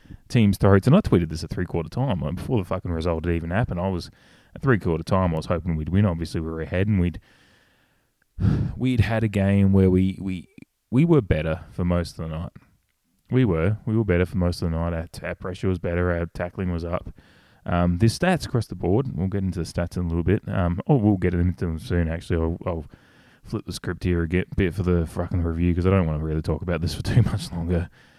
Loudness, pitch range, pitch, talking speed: -24 LUFS, 85-100 Hz, 90 Hz, 245 wpm